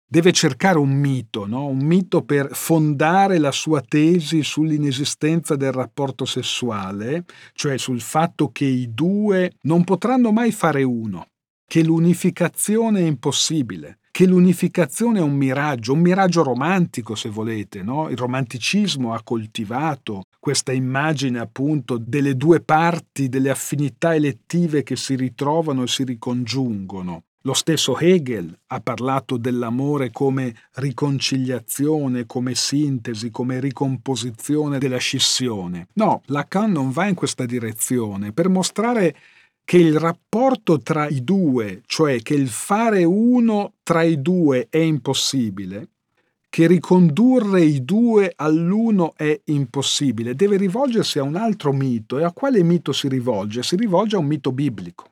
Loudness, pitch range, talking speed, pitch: -19 LUFS, 130-170 Hz, 135 wpm, 145 Hz